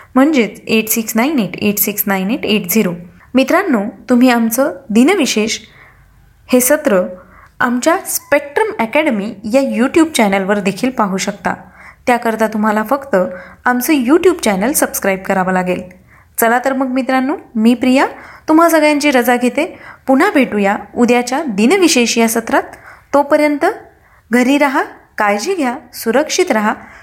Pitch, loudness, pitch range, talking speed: 245 Hz, -14 LUFS, 215-285 Hz, 130 wpm